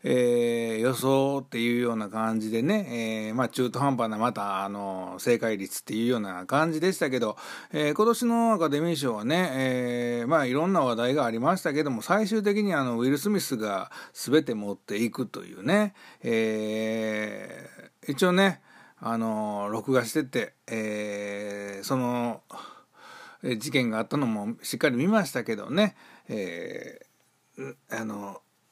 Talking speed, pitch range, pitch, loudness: 290 characters per minute, 110-150 Hz, 120 Hz, -27 LUFS